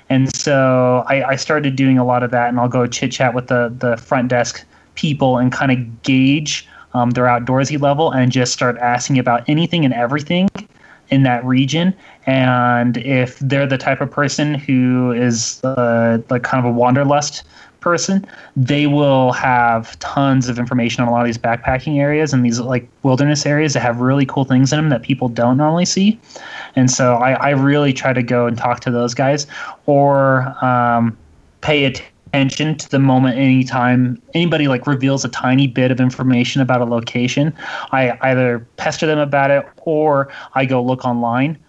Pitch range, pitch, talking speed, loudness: 125-140 Hz, 130 Hz, 185 wpm, -16 LUFS